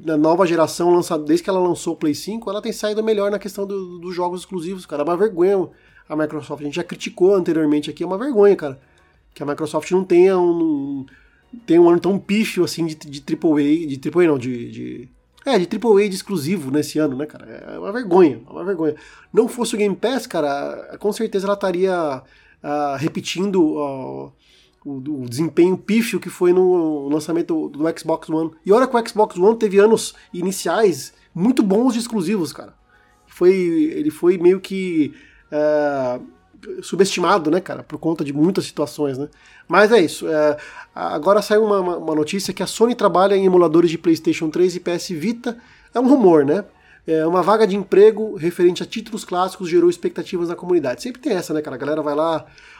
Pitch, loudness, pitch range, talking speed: 180 Hz, -19 LUFS, 155-205 Hz, 195 wpm